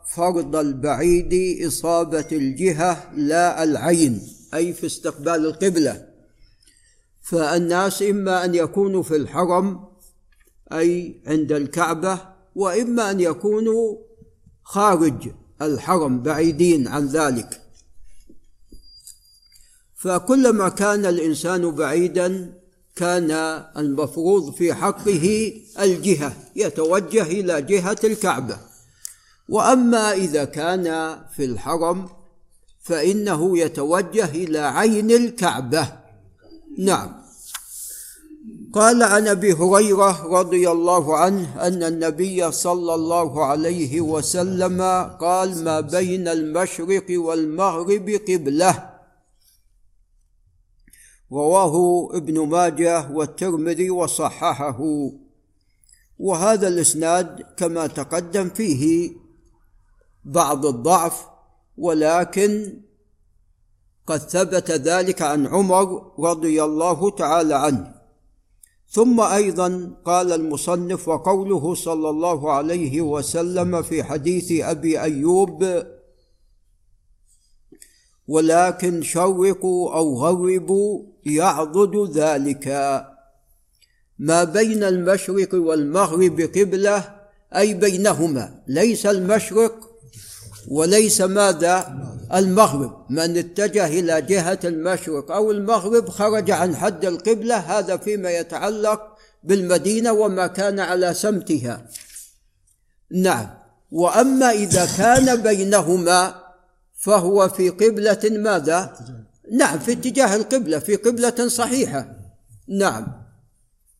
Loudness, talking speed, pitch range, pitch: -19 LUFS, 85 wpm, 160-200 Hz, 175 Hz